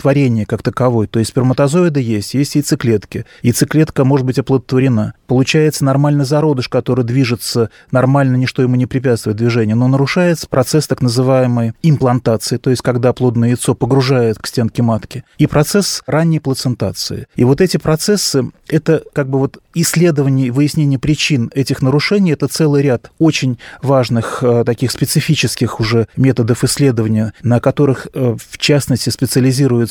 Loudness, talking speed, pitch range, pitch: -14 LUFS, 145 wpm, 120-145 Hz, 130 Hz